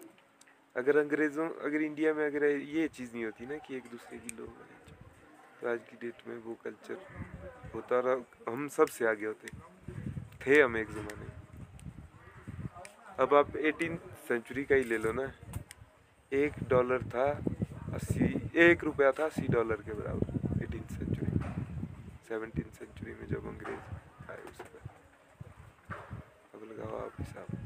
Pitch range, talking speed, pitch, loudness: 110-150 Hz, 150 wpm, 125 Hz, -32 LUFS